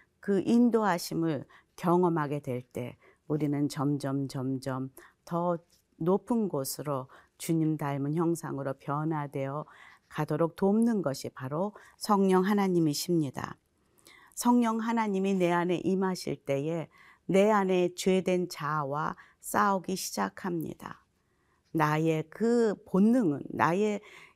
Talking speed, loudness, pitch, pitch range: 230 characters per minute, -29 LUFS, 170 Hz, 145-195 Hz